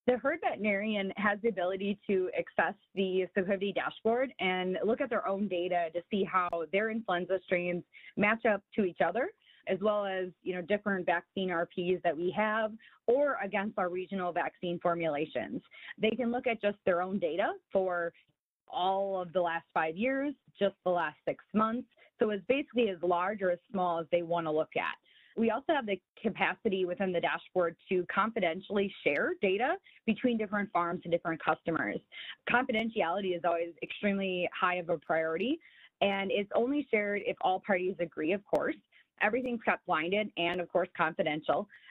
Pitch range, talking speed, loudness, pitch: 180-220 Hz, 175 wpm, -32 LUFS, 195 Hz